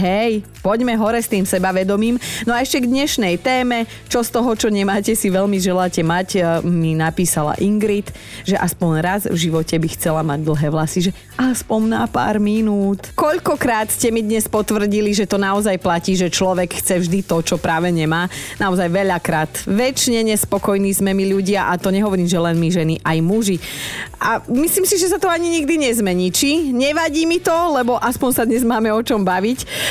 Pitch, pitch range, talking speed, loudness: 200 Hz, 180-235 Hz, 185 wpm, -17 LUFS